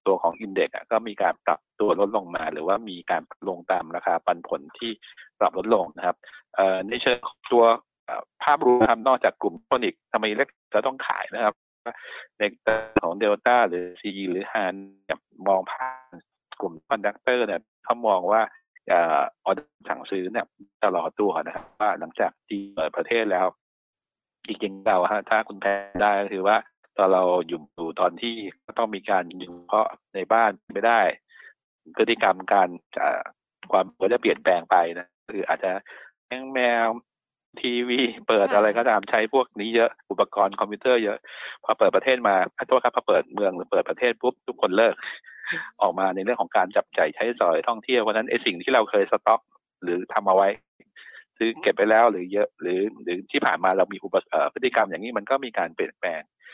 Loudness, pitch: -24 LUFS, 115 Hz